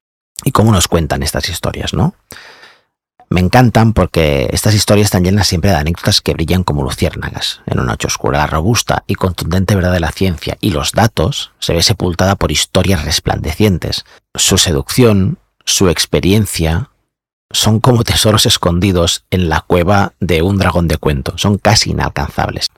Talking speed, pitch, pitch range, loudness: 160 wpm, 90 Hz, 80-105 Hz, -13 LUFS